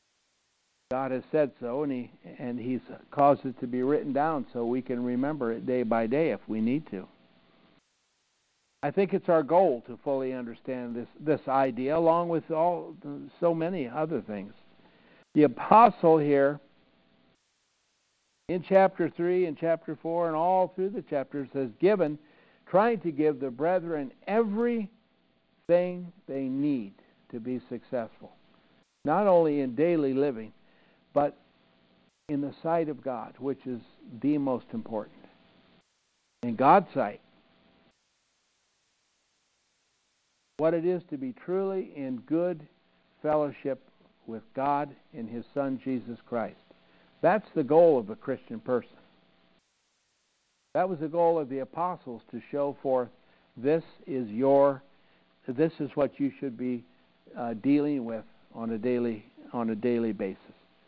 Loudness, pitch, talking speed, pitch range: -28 LUFS, 135 Hz, 140 wpm, 115-160 Hz